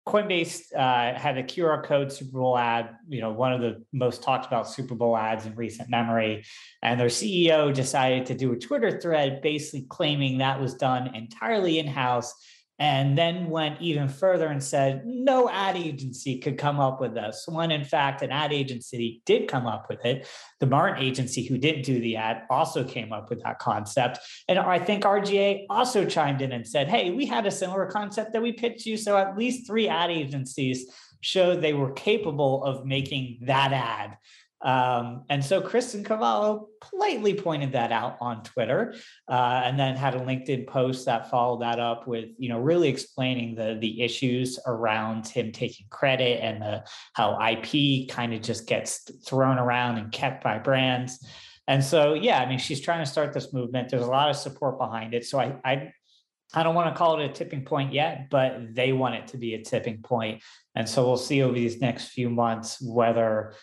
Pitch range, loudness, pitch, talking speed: 120-155 Hz, -26 LUFS, 130 Hz, 200 wpm